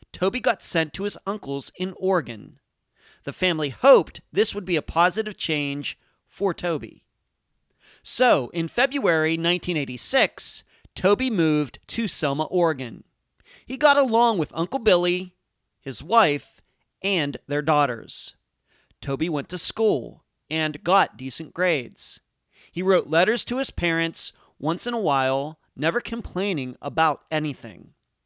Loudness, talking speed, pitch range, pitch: -23 LUFS, 130 wpm, 145-195 Hz, 165 Hz